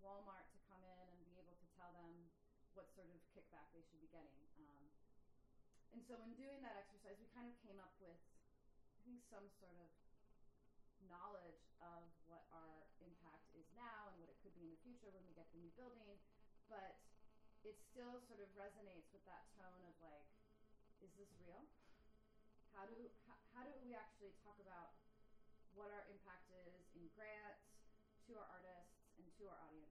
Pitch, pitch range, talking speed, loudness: 190 Hz, 170-210 Hz, 185 wpm, -63 LUFS